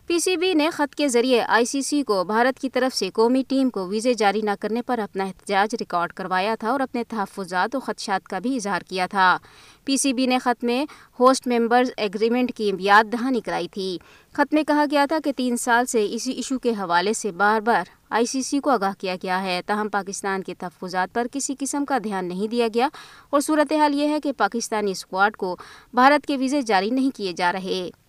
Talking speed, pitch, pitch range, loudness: 220 wpm, 235 Hz, 195-265 Hz, -22 LUFS